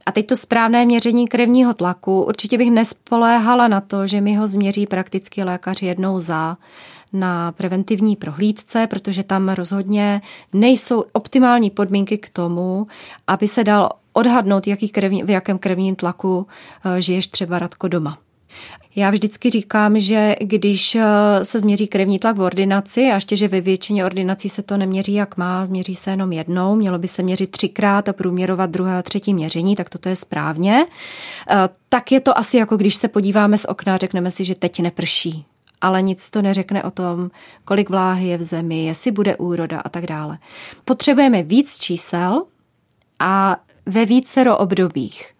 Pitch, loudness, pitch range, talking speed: 195 Hz, -17 LUFS, 185-215 Hz, 165 wpm